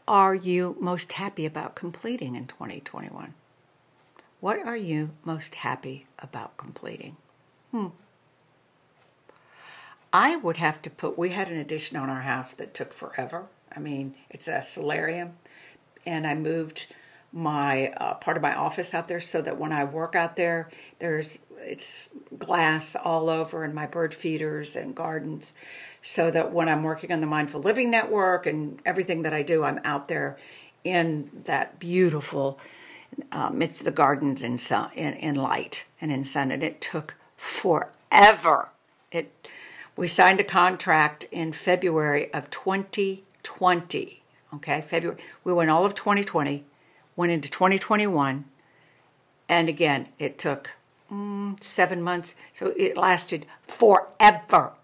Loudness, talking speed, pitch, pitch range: -25 LUFS, 145 wpm, 165 Hz, 150-185 Hz